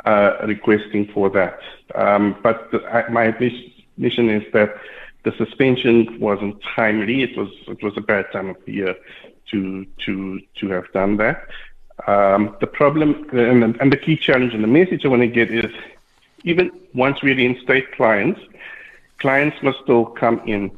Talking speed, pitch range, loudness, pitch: 180 wpm, 105-130 Hz, -18 LUFS, 115 Hz